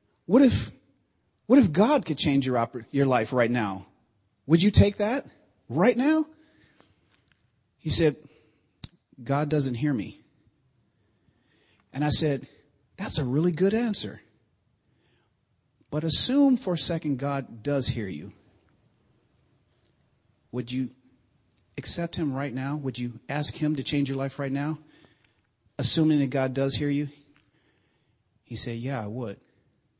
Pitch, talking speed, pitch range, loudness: 140 Hz, 135 wpm, 120-155 Hz, -26 LUFS